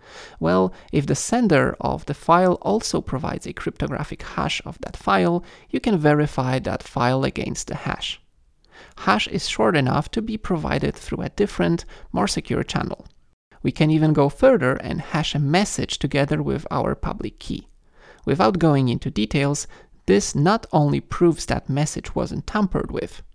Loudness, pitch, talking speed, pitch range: -22 LUFS, 145 Hz, 160 wpm, 125-170 Hz